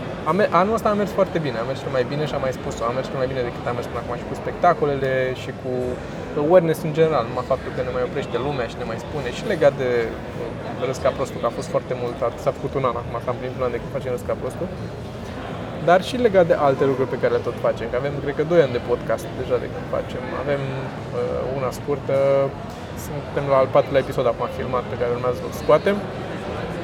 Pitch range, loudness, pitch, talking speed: 125-155 Hz, -22 LUFS, 135 Hz, 230 wpm